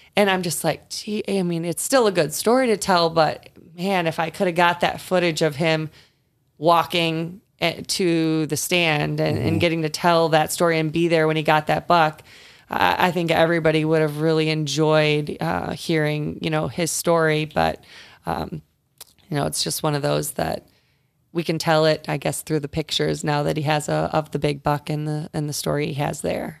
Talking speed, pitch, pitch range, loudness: 210 wpm, 160 Hz, 150-170 Hz, -21 LUFS